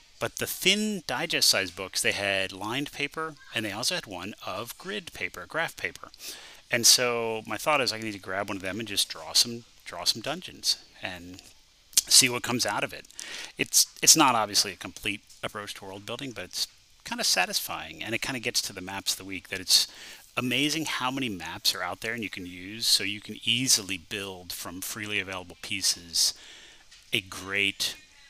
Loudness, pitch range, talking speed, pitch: -26 LUFS, 95-125 Hz, 205 wpm, 105 Hz